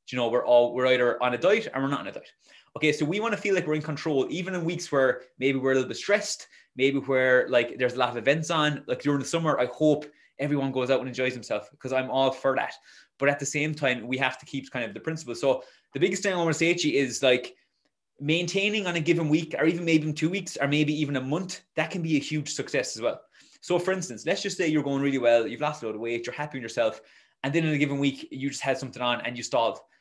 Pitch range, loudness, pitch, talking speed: 130-160 Hz, -26 LUFS, 140 Hz, 290 wpm